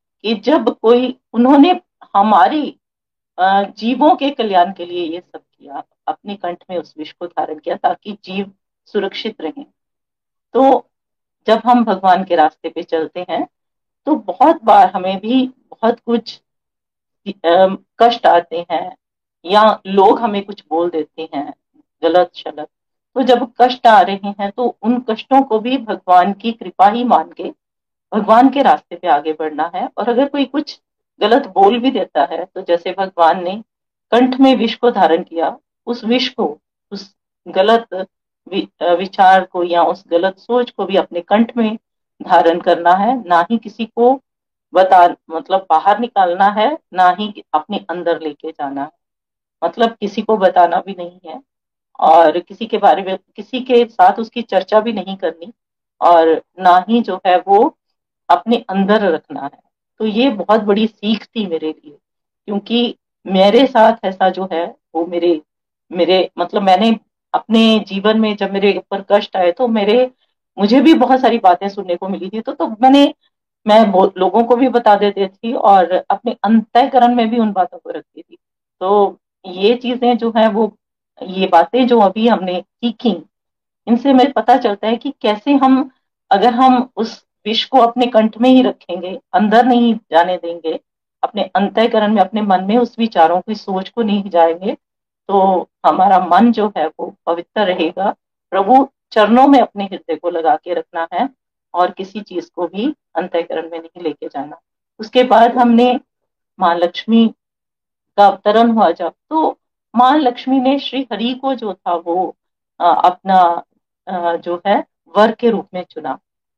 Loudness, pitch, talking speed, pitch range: -14 LUFS, 205 Hz, 165 wpm, 180-240 Hz